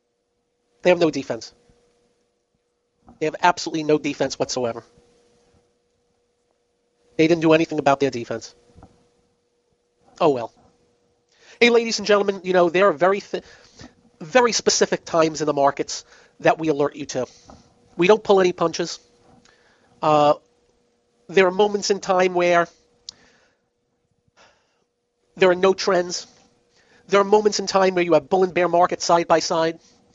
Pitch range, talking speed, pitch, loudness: 155-195 Hz, 140 wpm, 175 Hz, -20 LUFS